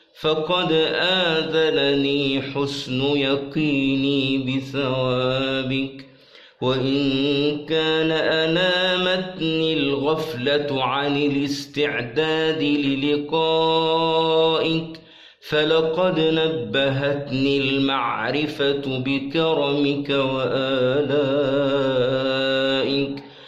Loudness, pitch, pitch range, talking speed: -21 LUFS, 140 Hz, 135-160 Hz, 45 wpm